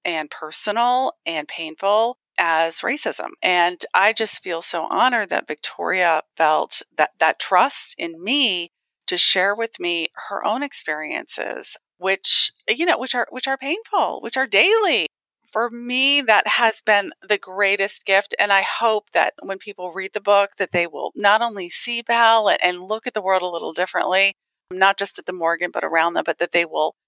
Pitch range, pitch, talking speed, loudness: 180-235 Hz, 200 Hz, 180 wpm, -20 LUFS